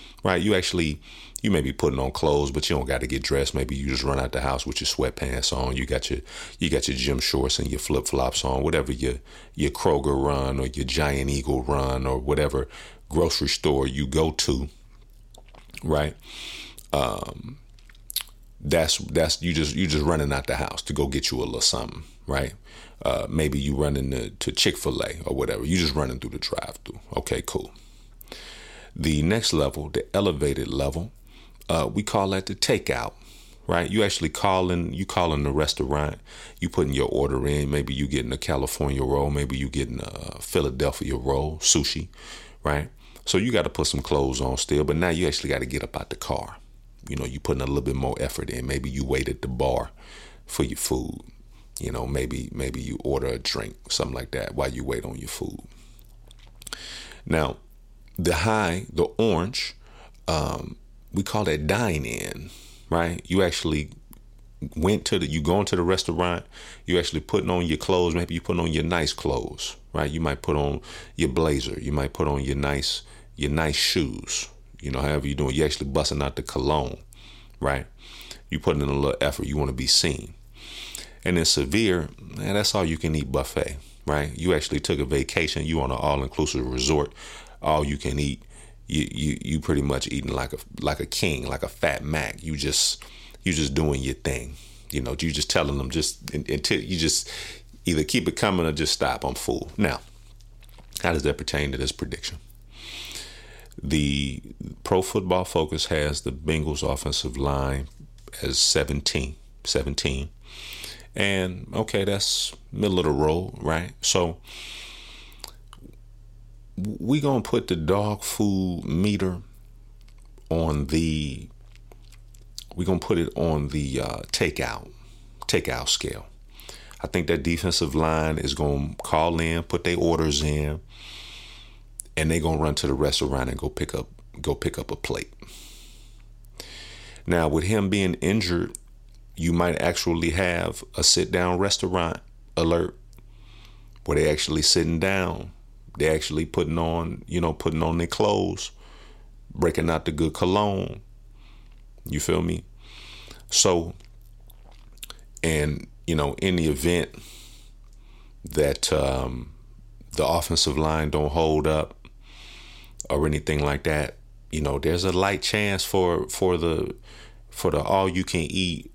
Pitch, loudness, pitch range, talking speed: 85 Hz, -25 LUFS, 75-105 Hz, 170 wpm